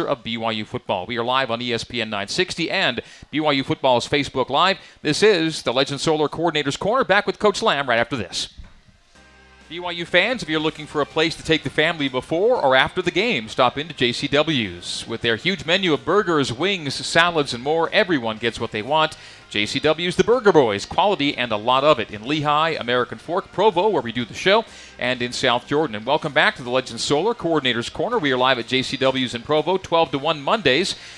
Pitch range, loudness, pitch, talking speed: 120-165 Hz, -20 LUFS, 145 Hz, 205 wpm